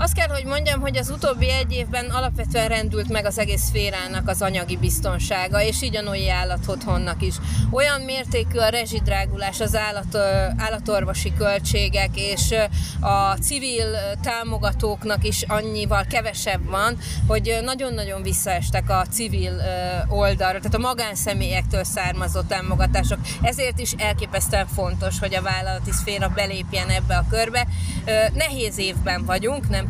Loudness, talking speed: -22 LUFS, 130 wpm